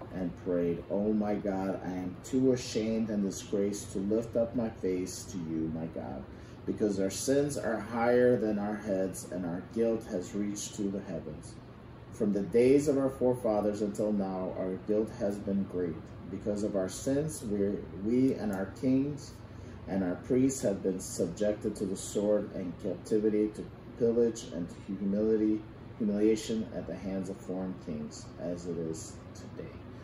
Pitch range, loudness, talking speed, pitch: 95-115 Hz, -32 LUFS, 170 wpm, 105 Hz